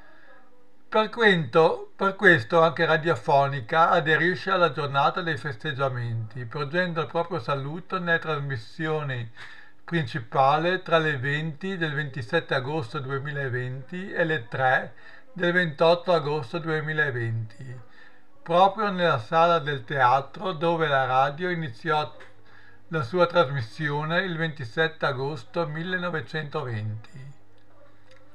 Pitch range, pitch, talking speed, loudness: 135-170 Hz, 155 Hz, 100 wpm, -25 LUFS